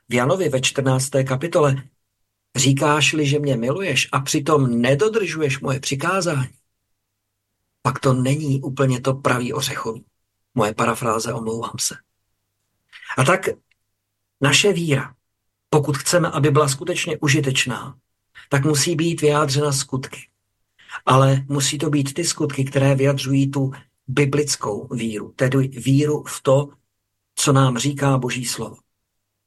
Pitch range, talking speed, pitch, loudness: 115-145 Hz, 120 wpm, 135 Hz, -20 LUFS